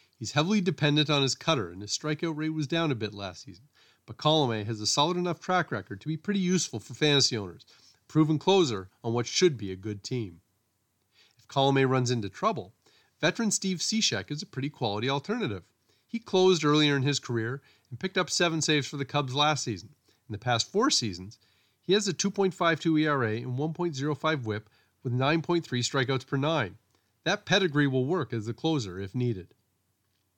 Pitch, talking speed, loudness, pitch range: 140 Hz, 190 wpm, -28 LUFS, 110-160 Hz